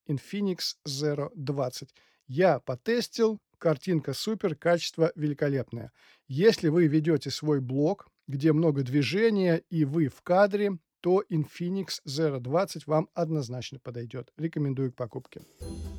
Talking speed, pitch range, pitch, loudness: 115 wpm, 140-175 Hz, 155 Hz, -28 LUFS